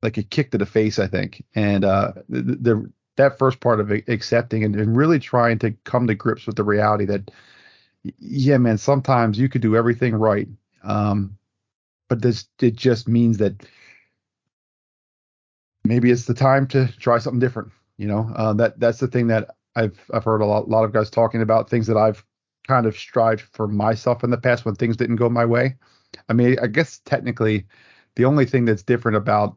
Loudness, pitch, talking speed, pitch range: -20 LUFS, 115 Hz, 200 wpm, 105-125 Hz